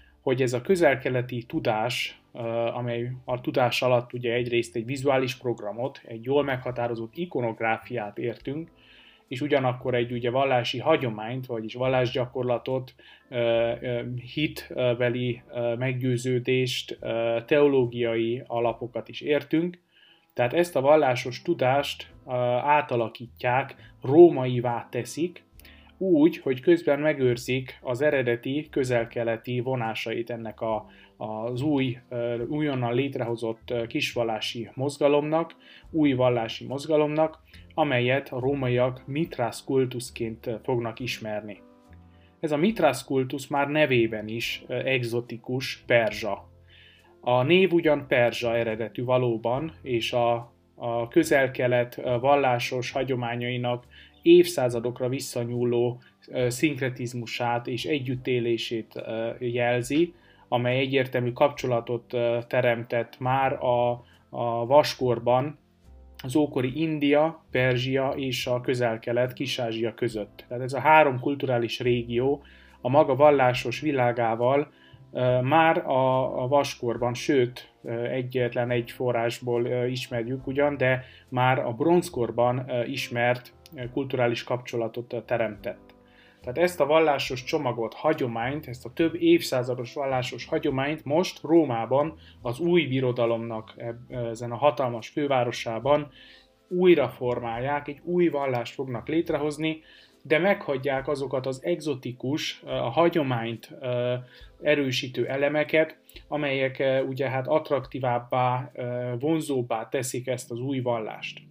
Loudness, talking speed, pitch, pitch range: -26 LUFS, 100 wpm, 125 Hz, 120-140 Hz